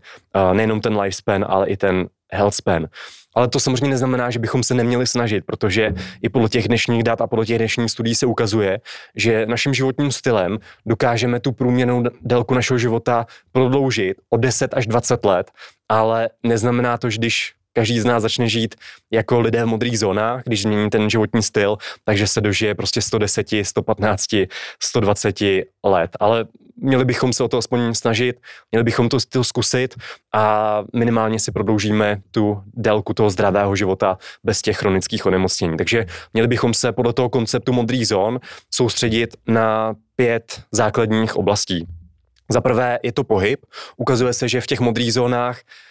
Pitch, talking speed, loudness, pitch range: 115 Hz, 165 wpm, -19 LUFS, 105-120 Hz